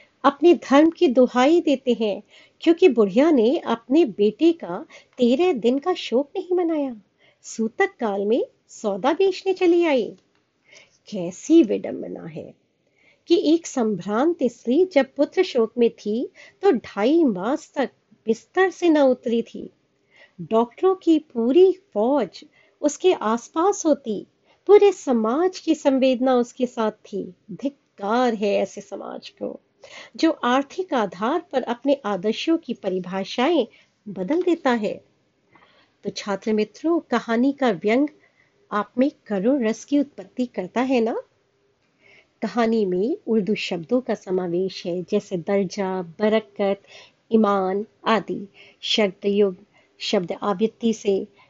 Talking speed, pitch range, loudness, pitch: 125 wpm, 210-315 Hz, -22 LUFS, 240 Hz